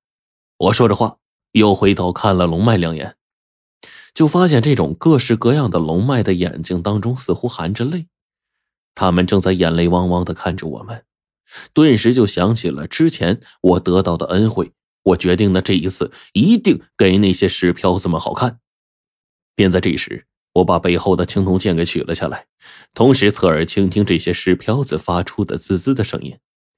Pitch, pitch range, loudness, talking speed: 95 Hz, 90-115 Hz, -16 LUFS, 260 characters per minute